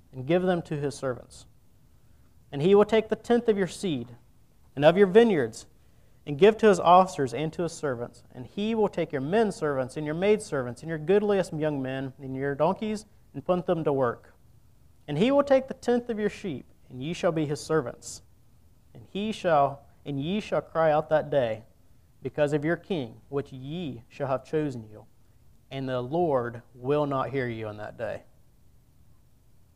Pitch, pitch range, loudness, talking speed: 145 Hz, 120-180 Hz, -26 LUFS, 195 wpm